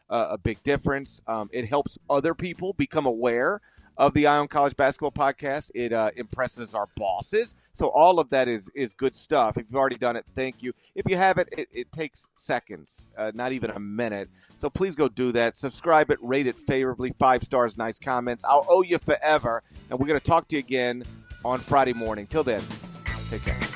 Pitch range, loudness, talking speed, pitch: 120-145 Hz, -25 LUFS, 205 wpm, 130 Hz